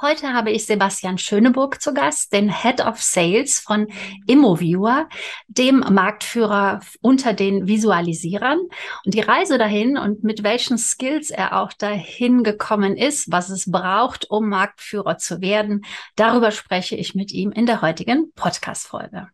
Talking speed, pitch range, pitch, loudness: 145 wpm, 195-245 Hz, 215 Hz, -19 LUFS